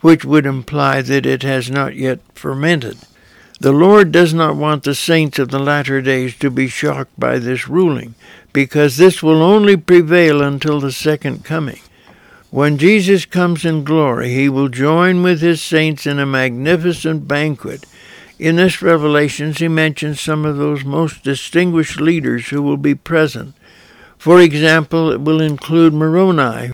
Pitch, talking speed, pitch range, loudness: 150 Hz, 160 wpm, 140-165 Hz, -14 LUFS